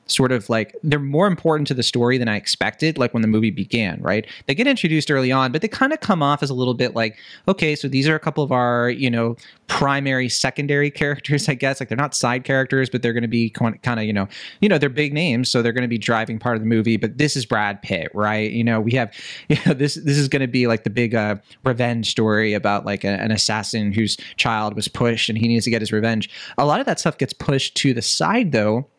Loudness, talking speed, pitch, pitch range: -20 LUFS, 265 wpm, 125 Hz, 115-145 Hz